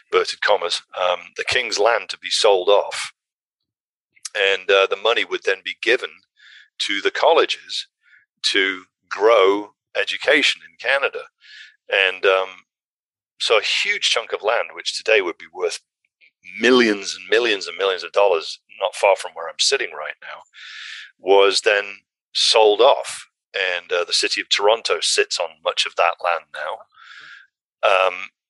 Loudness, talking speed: -19 LUFS, 150 wpm